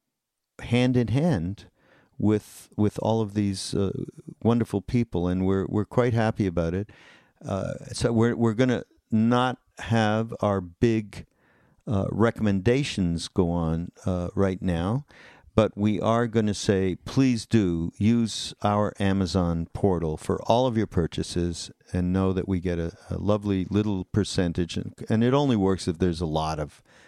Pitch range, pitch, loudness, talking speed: 90-115 Hz, 100 Hz, -25 LUFS, 160 wpm